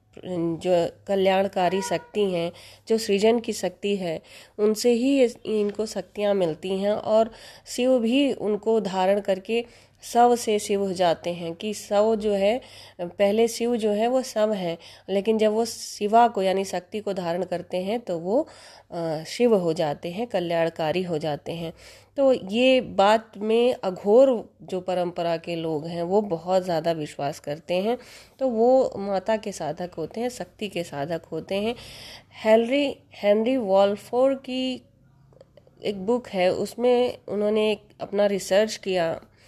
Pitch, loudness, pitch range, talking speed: 200 Hz, -24 LUFS, 175-225 Hz, 150 wpm